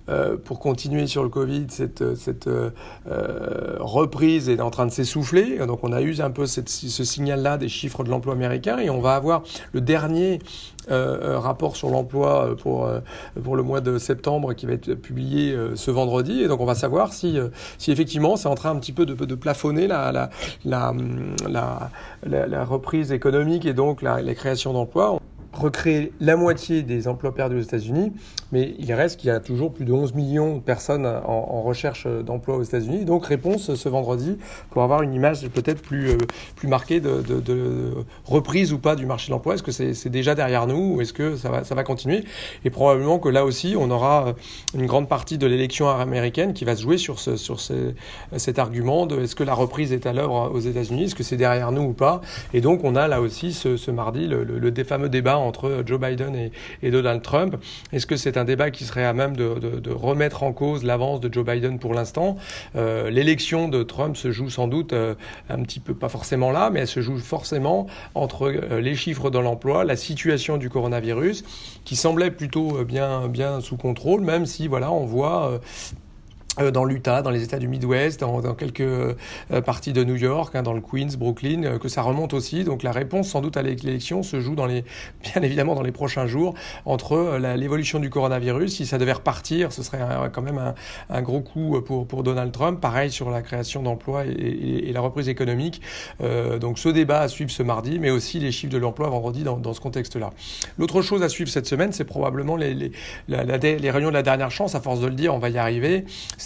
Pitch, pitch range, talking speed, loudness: 135 Hz, 125-150 Hz, 220 wpm, -23 LUFS